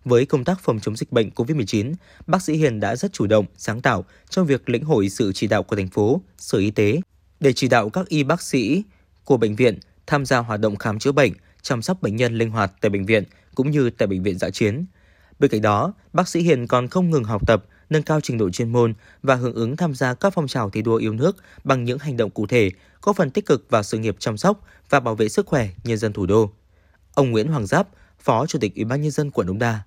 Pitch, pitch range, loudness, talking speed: 115 Hz, 105-145 Hz, -21 LUFS, 260 wpm